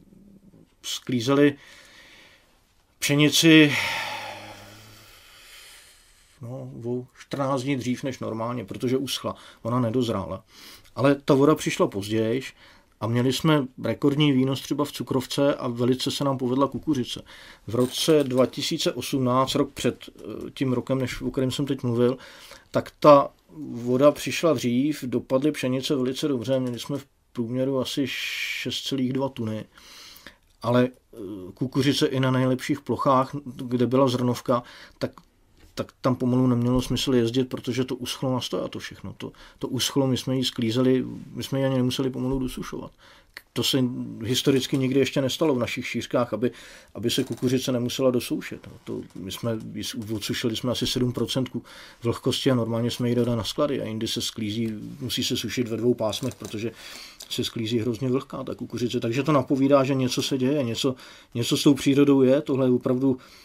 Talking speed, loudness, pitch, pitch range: 150 wpm, -24 LUFS, 130 Hz, 120-135 Hz